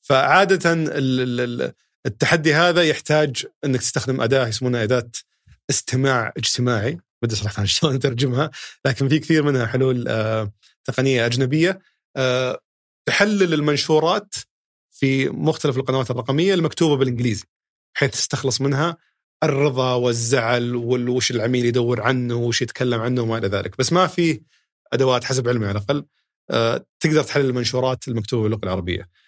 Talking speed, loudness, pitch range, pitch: 125 wpm, -20 LUFS, 120-150 Hz, 130 Hz